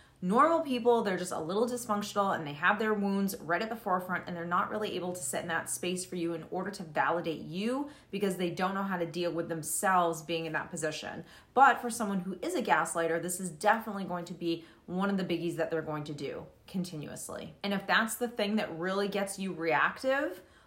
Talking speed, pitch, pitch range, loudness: 230 wpm, 185 Hz, 170-205 Hz, -32 LUFS